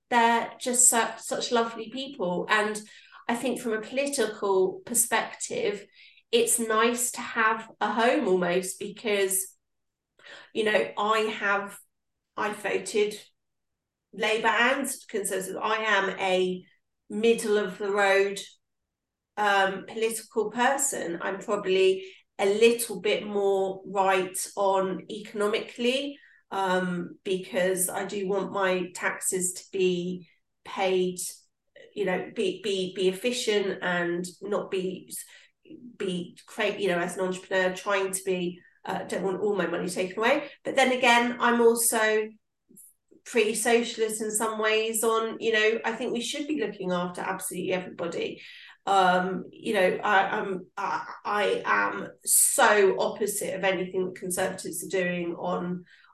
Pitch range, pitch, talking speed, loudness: 190-230 Hz, 205 Hz, 135 wpm, -26 LUFS